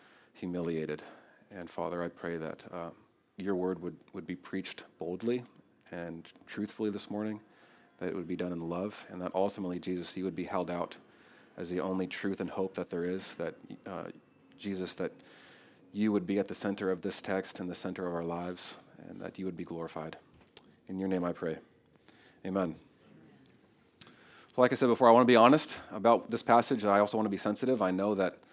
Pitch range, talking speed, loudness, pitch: 90-105 Hz, 205 wpm, -33 LUFS, 95 Hz